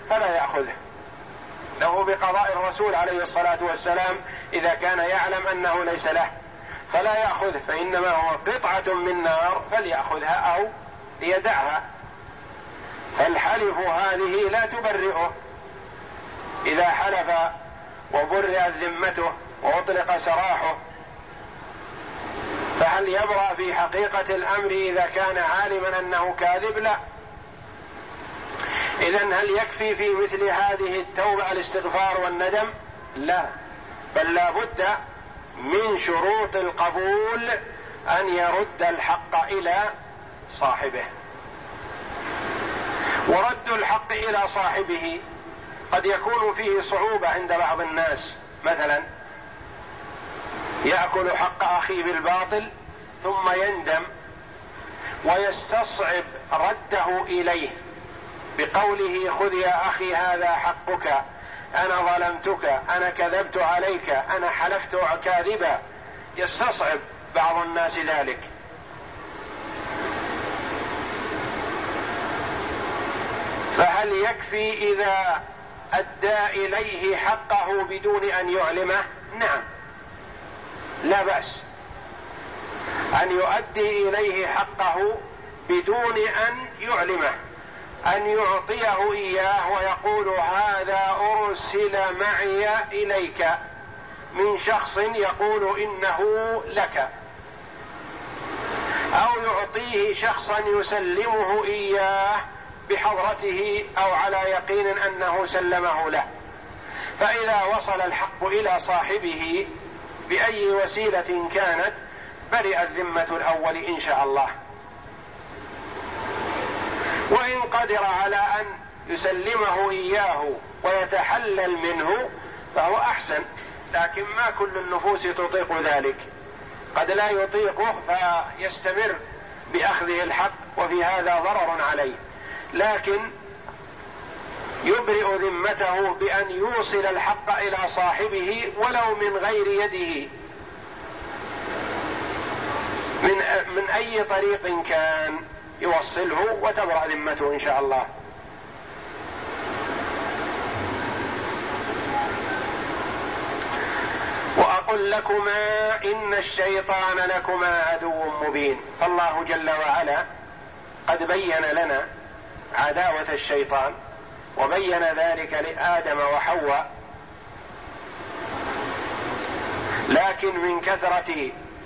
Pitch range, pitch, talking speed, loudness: 175-210 Hz, 190 Hz, 80 wpm, -23 LUFS